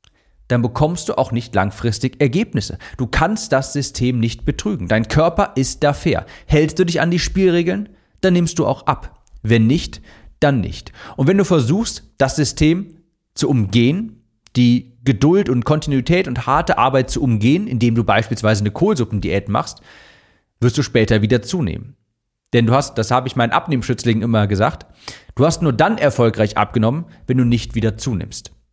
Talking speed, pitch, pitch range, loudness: 170 wpm, 125 Hz, 115-155 Hz, -17 LUFS